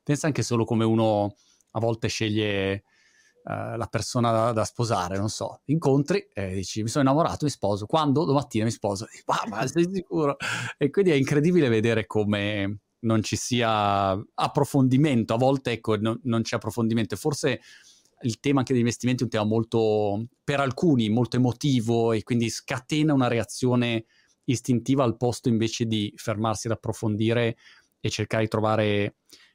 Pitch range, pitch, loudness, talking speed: 110-135 Hz, 115 Hz, -25 LUFS, 160 wpm